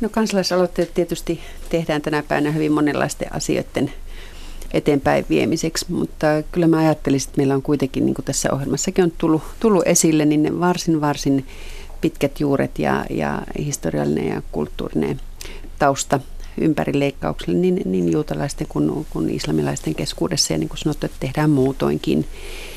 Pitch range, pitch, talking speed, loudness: 135-170 Hz, 150 Hz, 145 wpm, -20 LUFS